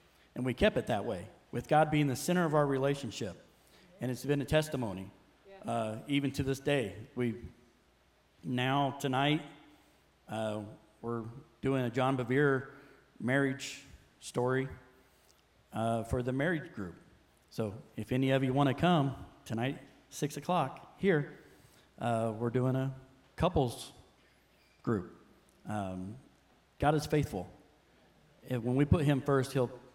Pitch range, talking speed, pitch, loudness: 115-140 Hz, 140 wpm, 130 Hz, -33 LUFS